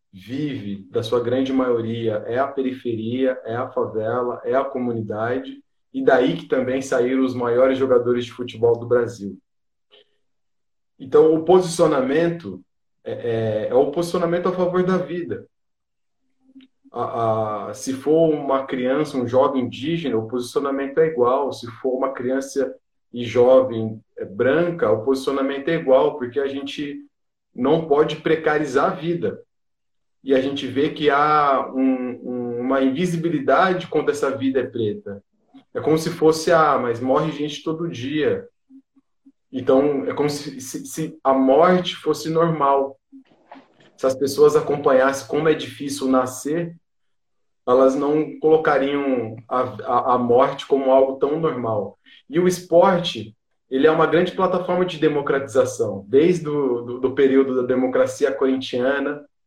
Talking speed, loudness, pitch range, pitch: 145 wpm, -20 LUFS, 125-170 Hz, 140 Hz